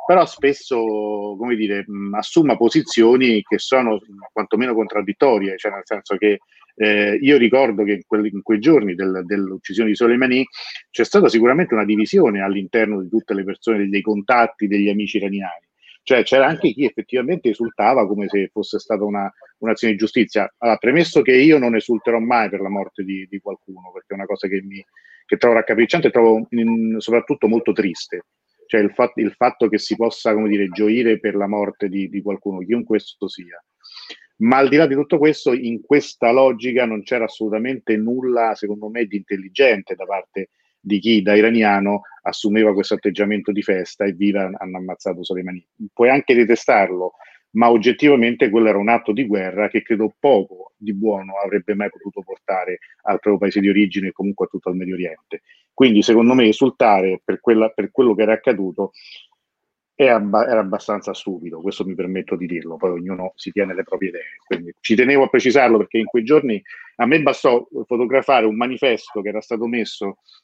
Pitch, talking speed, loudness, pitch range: 110 Hz, 185 wpm, -18 LUFS, 100-120 Hz